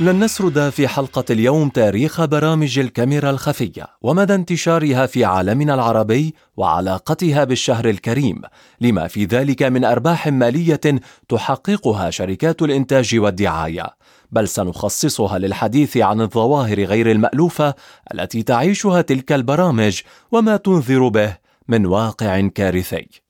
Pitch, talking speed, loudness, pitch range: 130 Hz, 115 wpm, -17 LUFS, 110-150 Hz